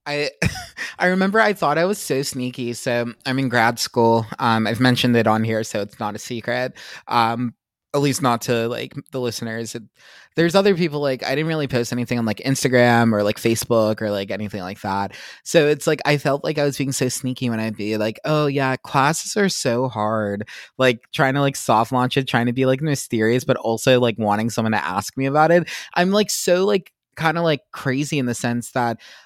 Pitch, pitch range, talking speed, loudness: 125 Hz, 115-145 Hz, 220 wpm, -20 LUFS